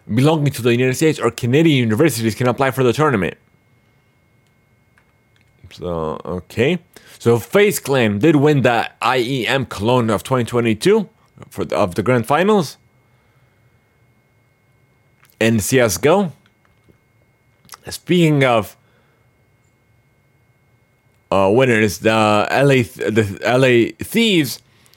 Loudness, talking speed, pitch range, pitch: -16 LUFS, 105 wpm, 115-130 Hz, 120 Hz